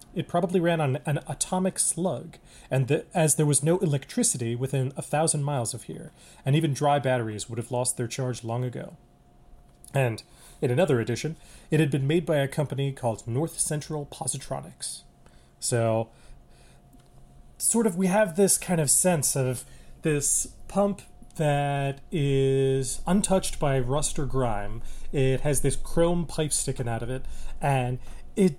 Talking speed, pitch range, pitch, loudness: 160 wpm, 125-160 Hz, 140 Hz, -26 LUFS